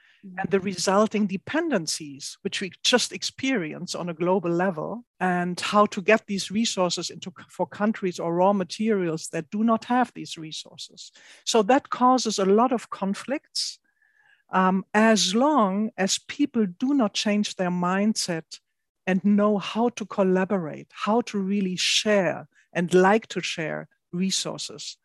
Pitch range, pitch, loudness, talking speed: 185-225 Hz, 200 Hz, -24 LUFS, 145 wpm